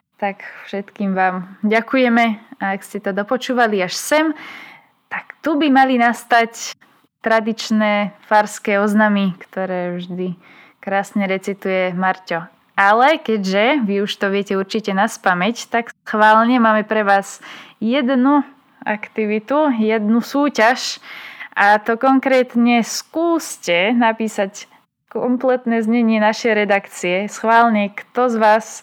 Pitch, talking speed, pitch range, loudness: 220 Hz, 115 wpm, 200-245 Hz, -17 LUFS